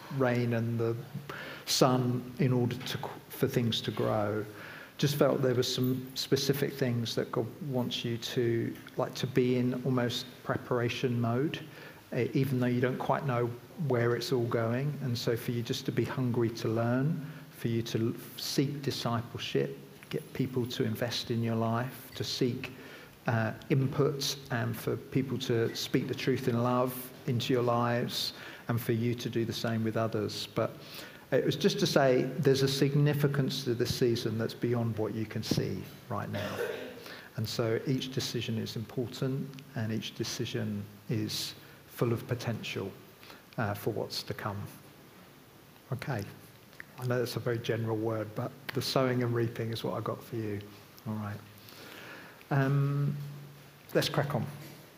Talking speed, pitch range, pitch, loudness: 165 wpm, 115-135 Hz, 125 Hz, -32 LUFS